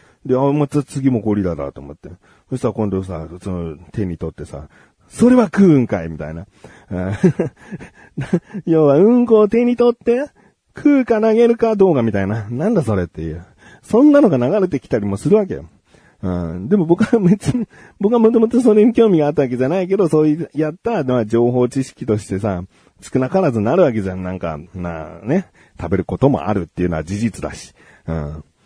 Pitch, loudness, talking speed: 130 Hz, -16 LUFS, 365 characters per minute